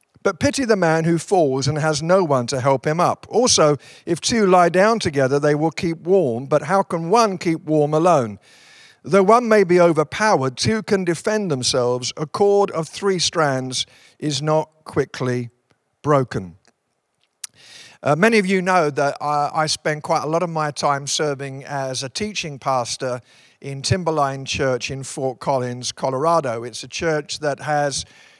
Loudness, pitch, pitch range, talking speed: -19 LUFS, 150 Hz, 135-175 Hz, 170 wpm